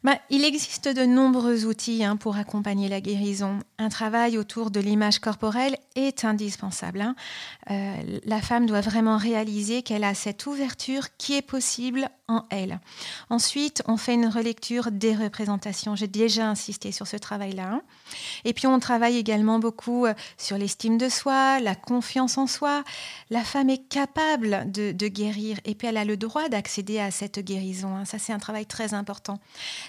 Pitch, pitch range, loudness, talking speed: 220 Hz, 205-250 Hz, -26 LUFS, 175 wpm